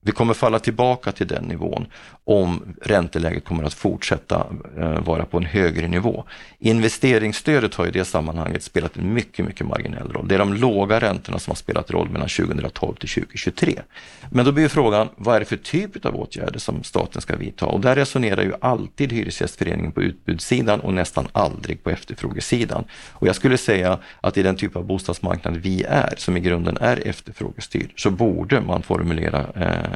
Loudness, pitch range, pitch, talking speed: -21 LUFS, 85-110 Hz, 95 Hz, 180 wpm